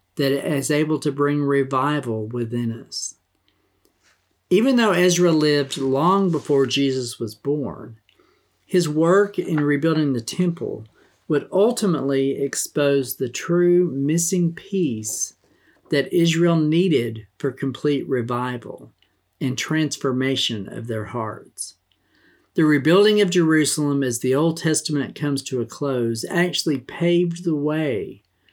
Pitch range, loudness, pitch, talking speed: 130-170 Hz, -21 LUFS, 145 Hz, 120 wpm